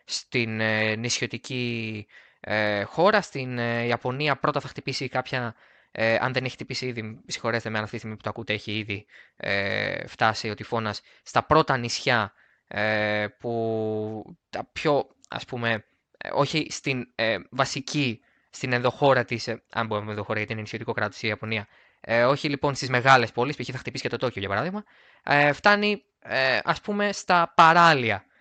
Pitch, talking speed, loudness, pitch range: 120 Hz, 170 wpm, -25 LUFS, 110-135 Hz